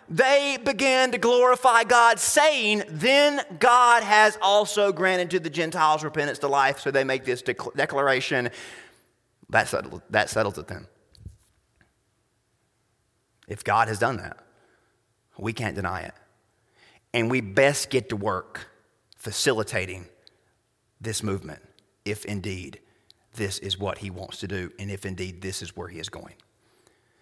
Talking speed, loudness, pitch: 140 wpm, -23 LUFS, 125 Hz